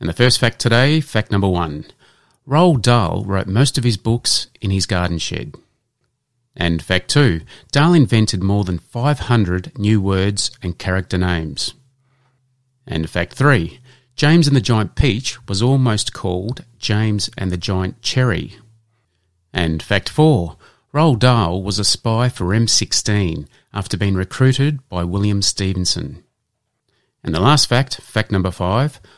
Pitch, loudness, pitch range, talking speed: 110 Hz, -17 LUFS, 95-130 Hz, 145 wpm